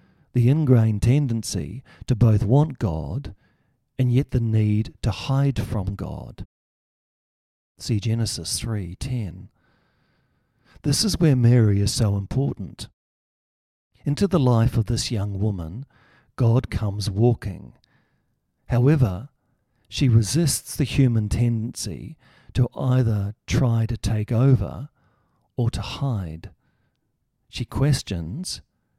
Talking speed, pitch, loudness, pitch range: 110 wpm, 115 Hz, -22 LUFS, 105-130 Hz